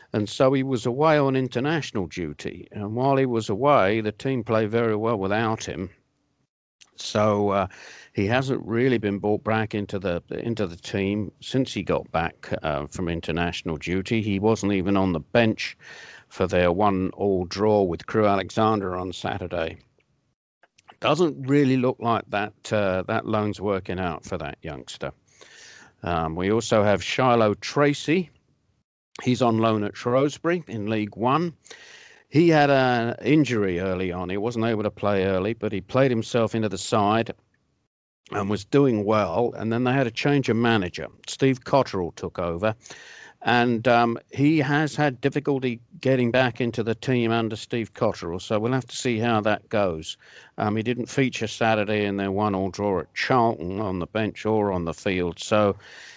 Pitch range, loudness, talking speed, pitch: 100-125 Hz, -24 LUFS, 170 wpm, 110 Hz